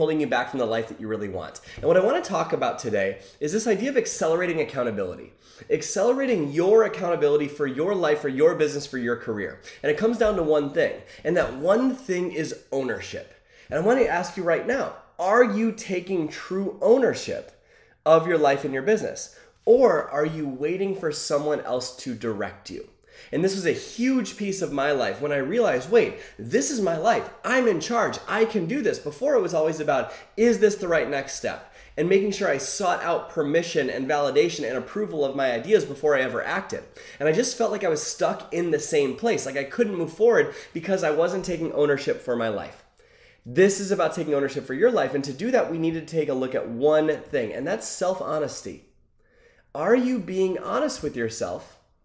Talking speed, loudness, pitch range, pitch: 215 wpm, -24 LUFS, 145-235 Hz, 175 Hz